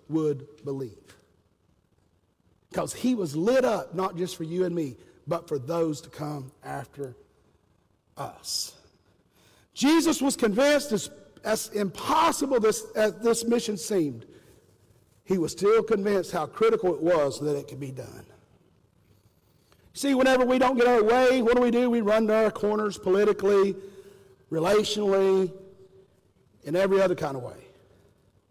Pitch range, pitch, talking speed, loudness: 140-220 Hz, 190 Hz, 145 wpm, -25 LUFS